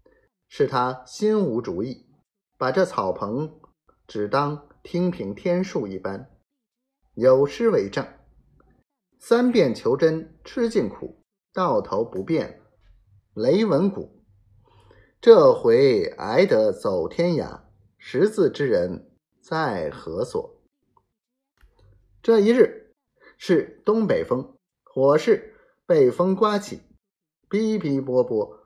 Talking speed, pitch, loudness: 140 characters per minute, 200 Hz, -22 LUFS